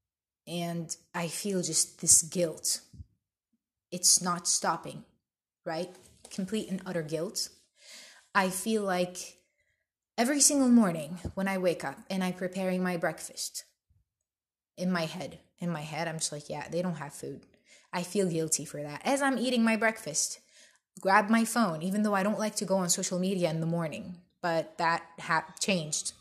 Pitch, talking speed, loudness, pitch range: 180 Hz, 165 wpm, -29 LUFS, 165-195 Hz